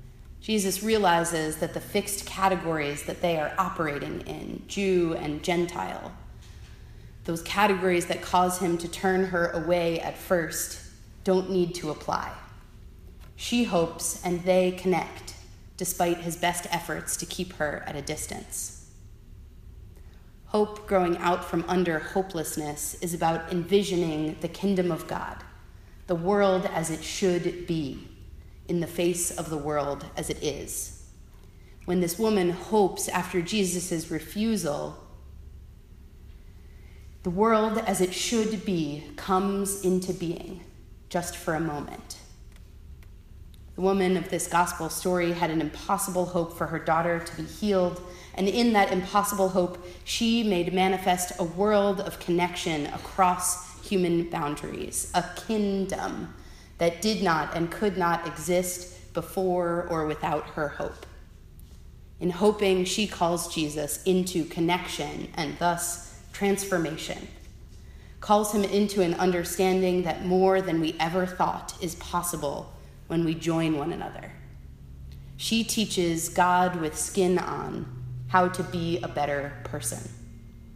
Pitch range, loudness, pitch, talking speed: 155-185 Hz, -27 LUFS, 175 Hz, 130 wpm